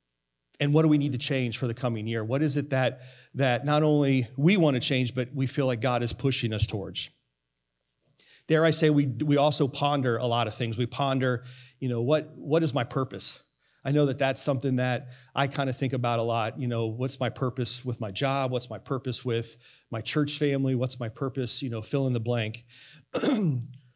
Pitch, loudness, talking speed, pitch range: 130 Hz, -27 LUFS, 220 wpm, 120-140 Hz